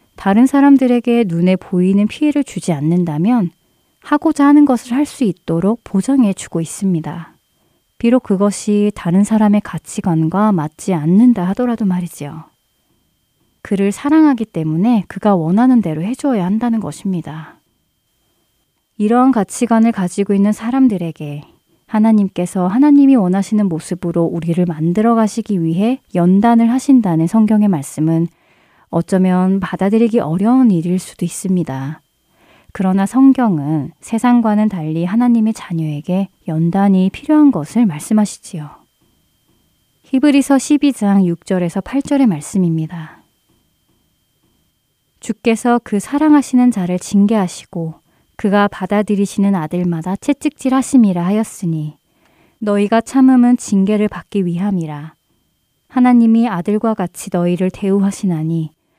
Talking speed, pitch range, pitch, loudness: 300 characters per minute, 175-235 Hz, 200 Hz, -14 LUFS